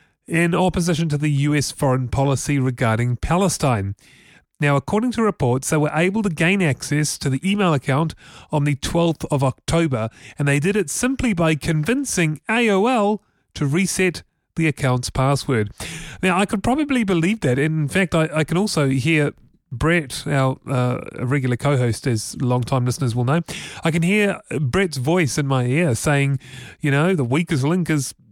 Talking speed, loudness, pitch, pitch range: 170 wpm, -20 LUFS, 150 Hz, 135-175 Hz